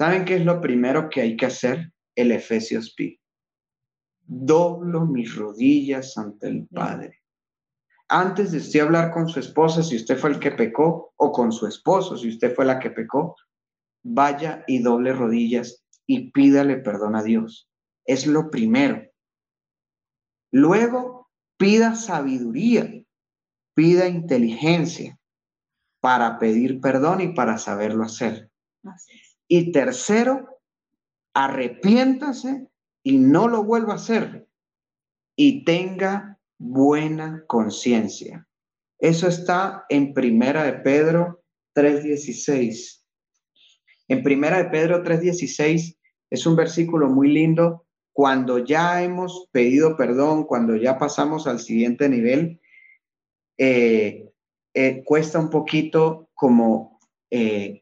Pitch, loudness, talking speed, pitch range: 155 Hz, -20 LUFS, 115 wpm, 125-180 Hz